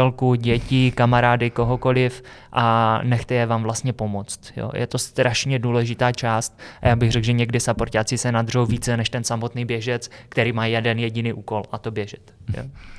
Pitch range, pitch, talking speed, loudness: 115-125 Hz, 120 Hz, 175 wpm, -21 LUFS